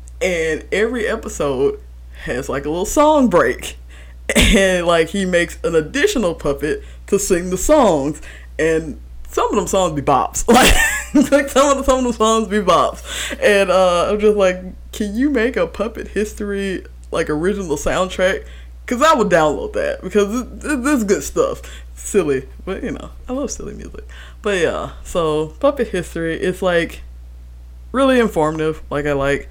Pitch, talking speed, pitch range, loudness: 180 Hz, 170 wpm, 140-215 Hz, -17 LUFS